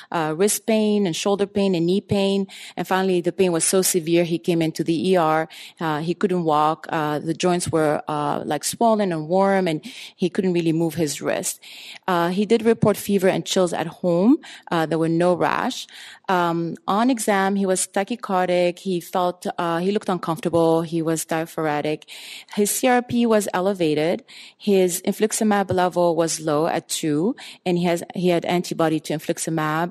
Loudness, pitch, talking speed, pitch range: -21 LUFS, 180 Hz, 180 wpm, 165-195 Hz